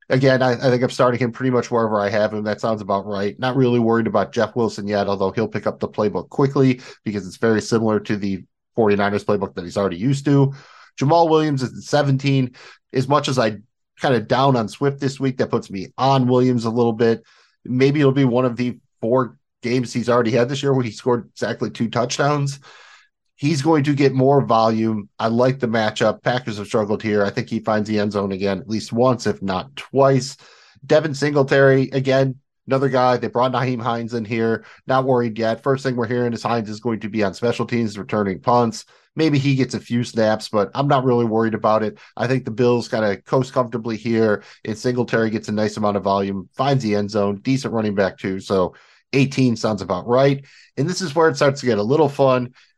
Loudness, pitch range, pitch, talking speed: -20 LUFS, 110-135 Hz, 120 Hz, 225 wpm